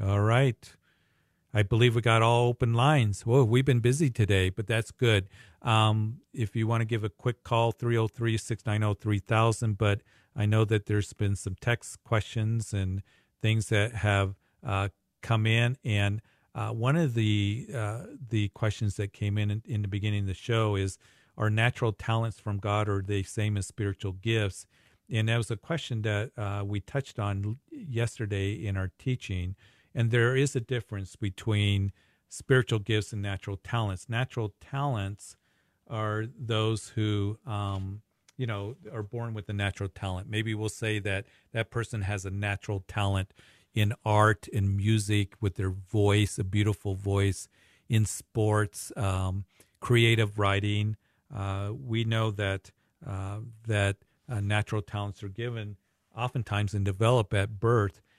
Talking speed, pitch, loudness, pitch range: 155 wpm, 105 Hz, -29 LUFS, 100-115 Hz